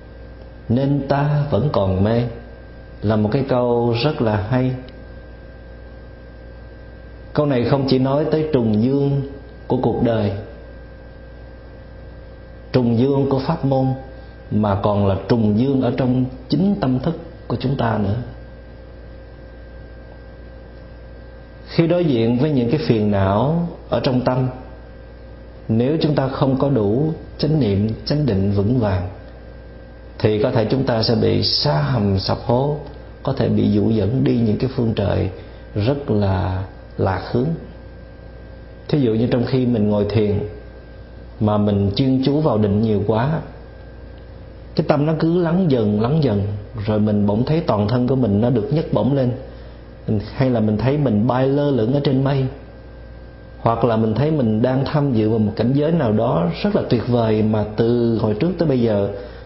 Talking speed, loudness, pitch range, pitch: 165 wpm, -19 LUFS, 100-135 Hz, 115 Hz